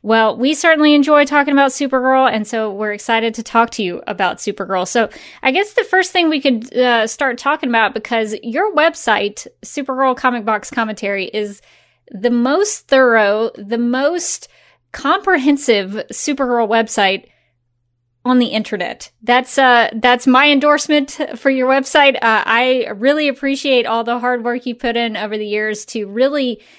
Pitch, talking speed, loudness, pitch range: 245 Hz, 160 wpm, -15 LUFS, 220-275 Hz